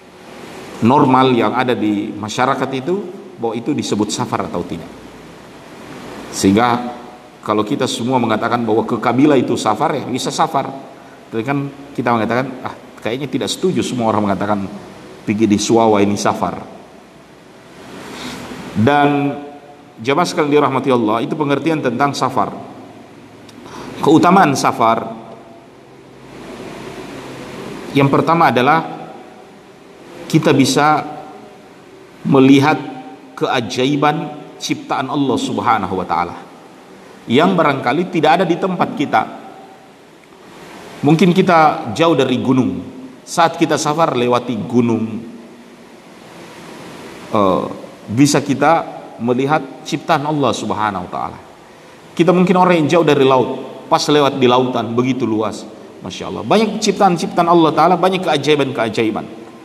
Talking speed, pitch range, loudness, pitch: 110 wpm, 115-150 Hz, -15 LUFS, 130 Hz